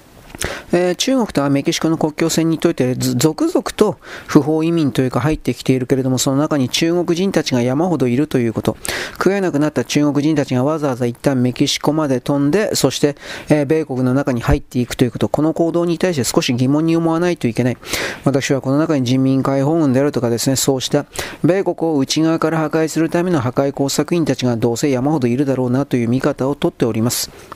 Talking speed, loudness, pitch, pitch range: 425 characters per minute, -17 LUFS, 145 Hz, 130-160 Hz